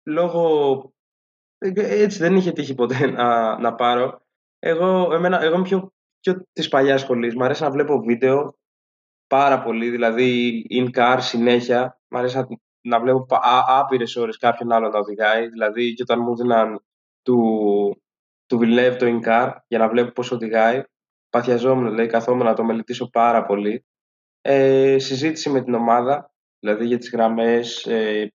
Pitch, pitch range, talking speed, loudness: 120 Hz, 115-135 Hz, 145 wpm, -19 LUFS